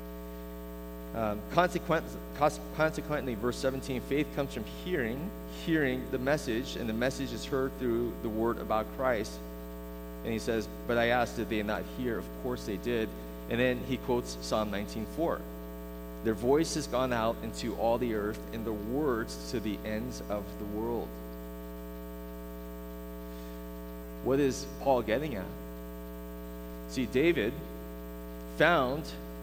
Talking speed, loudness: 140 wpm, -32 LUFS